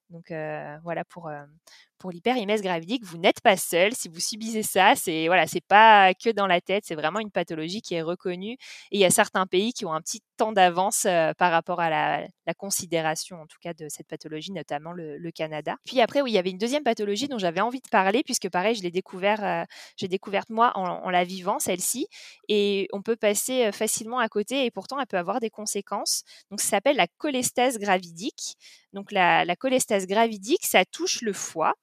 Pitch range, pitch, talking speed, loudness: 175-225 Hz, 195 Hz, 220 wpm, -24 LUFS